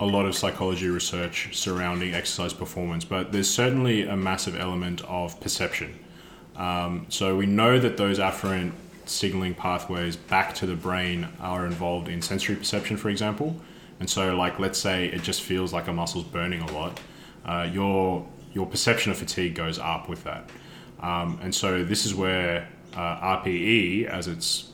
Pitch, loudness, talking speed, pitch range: 90 Hz, -26 LUFS, 170 wpm, 90-100 Hz